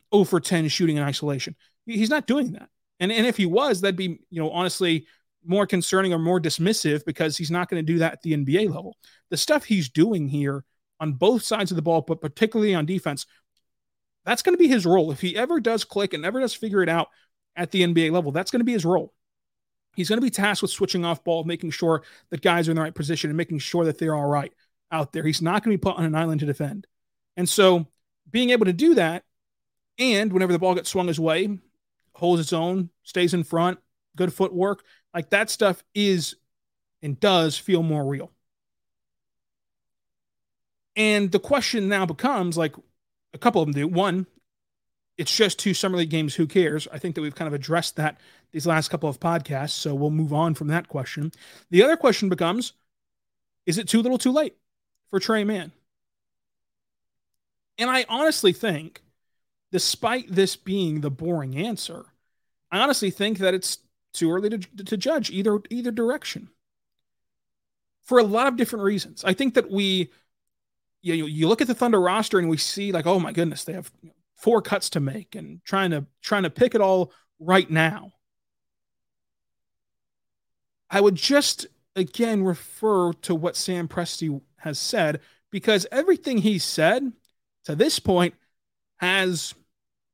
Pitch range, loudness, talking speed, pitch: 160-205 Hz, -23 LUFS, 190 wpm, 180 Hz